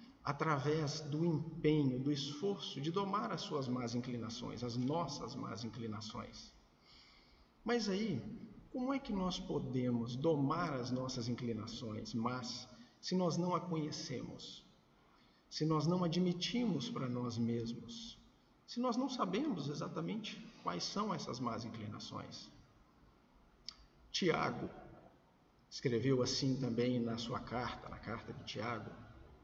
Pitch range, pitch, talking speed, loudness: 120-175 Hz, 145 Hz, 120 wpm, -39 LUFS